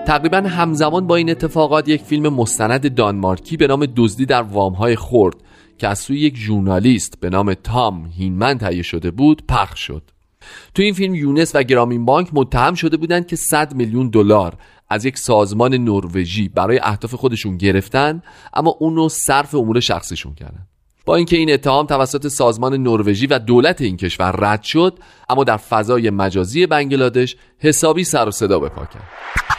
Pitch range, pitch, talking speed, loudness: 100-150 Hz, 125 Hz, 170 wpm, -16 LUFS